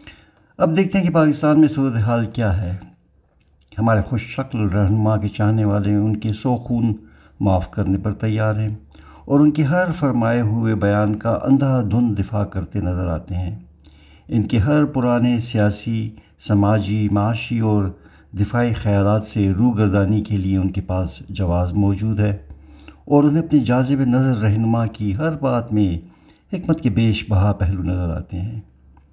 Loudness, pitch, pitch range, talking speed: -19 LUFS, 105 Hz, 95-120 Hz, 160 wpm